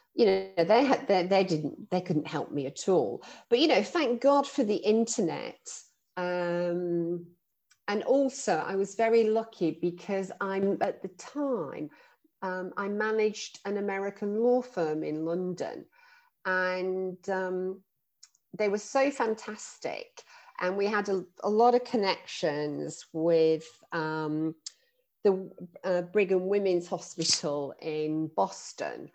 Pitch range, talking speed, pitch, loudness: 175-225 Hz, 135 wpm, 195 Hz, -29 LUFS